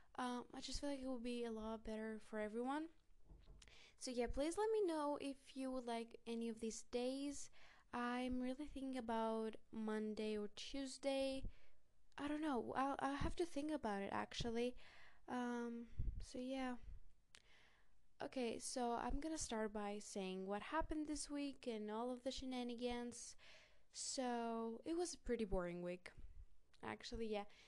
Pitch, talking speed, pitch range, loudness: 245 Hz, 160 wpm, 225-275 Hz, -47 LUFS